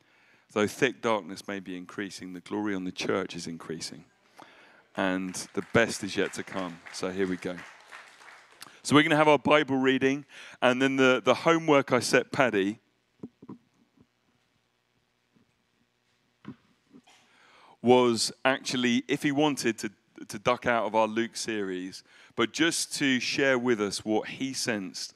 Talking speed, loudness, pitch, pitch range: 150 wpm, -27 LUFS, 115 Hz, 95-135 Hz